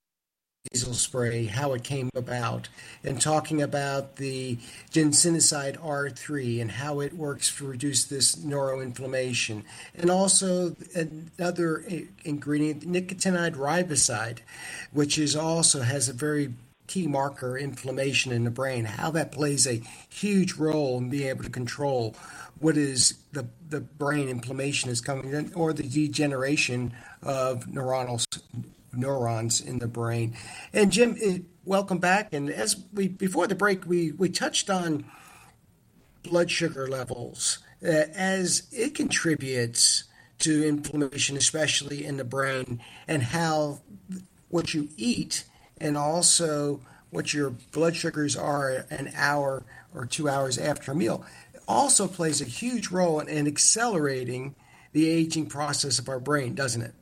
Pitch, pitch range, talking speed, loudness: 145 Hz, 130-165 Hz, 135 wpm, -26 LUFS